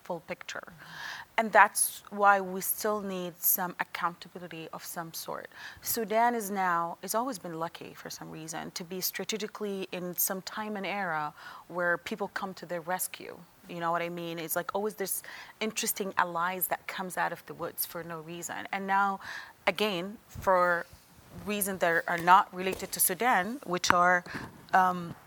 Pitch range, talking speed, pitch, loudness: 175-200 Hz, 170 wpm, 185 Hz, -30 LUFS